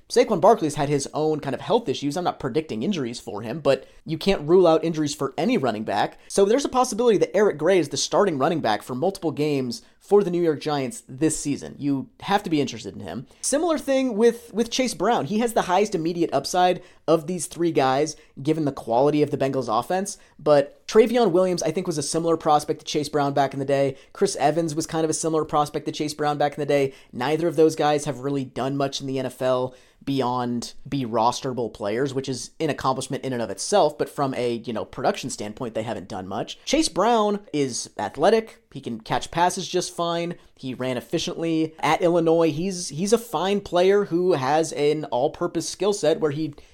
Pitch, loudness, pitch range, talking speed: 155 Hz, -23 LUFS, 135-180 Hz, 220 wpm